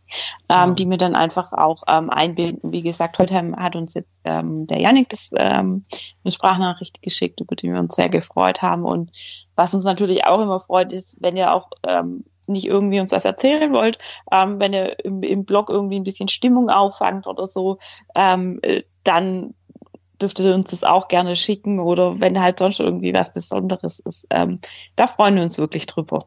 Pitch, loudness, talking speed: 185 Hz, -19 LUFS, 190 wpm